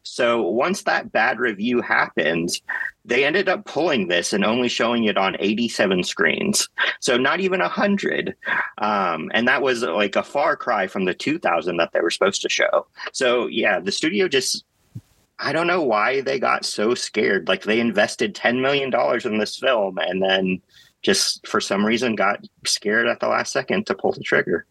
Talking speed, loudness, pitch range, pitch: 185 wpm, -20 LUFS, 100-135 Hz, 115 Hz